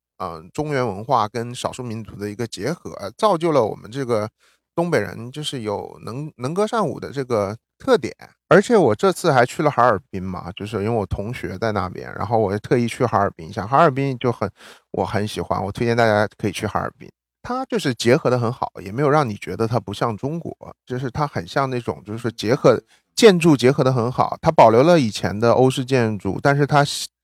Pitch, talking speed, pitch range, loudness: 120 Hz, 315 characters per minute, 105-140 Hz, -20 LUFS